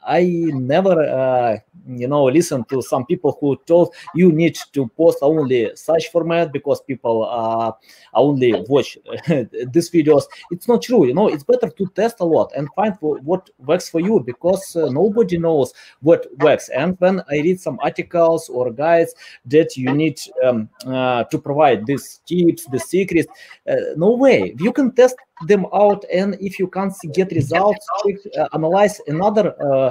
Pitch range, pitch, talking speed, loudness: 140-190 Hz, 165 Hz, 175 wpm, -18 LUFS